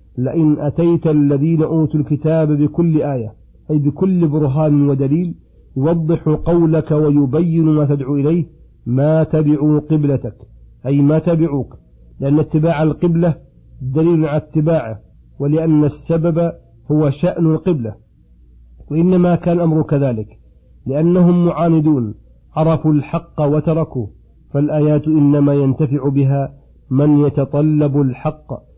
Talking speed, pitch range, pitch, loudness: 105 wpm, 140-160 Hz, 150 Hz, -15 LUFS